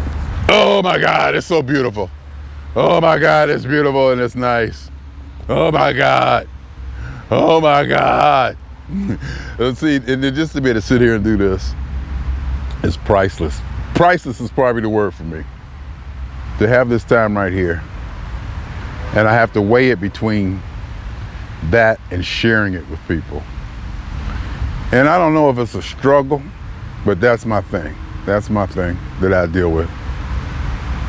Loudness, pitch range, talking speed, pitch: -16 LUFS, 75-120 Hz, 155 wpm, 95 Hz